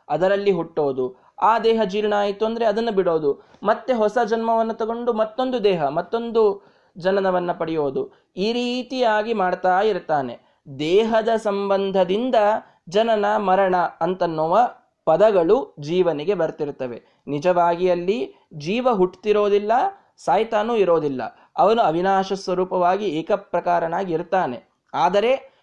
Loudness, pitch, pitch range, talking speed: -21 LUFS, 195 Hz, 175-225 Hz, 95 wpm